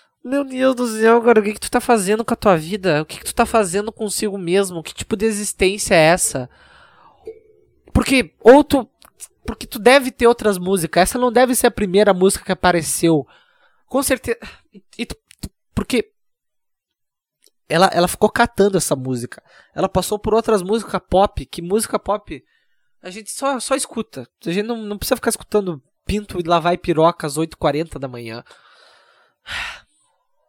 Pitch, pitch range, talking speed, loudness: 215 Hz, 180-245 Hz, 170 wpm, -18 LUFS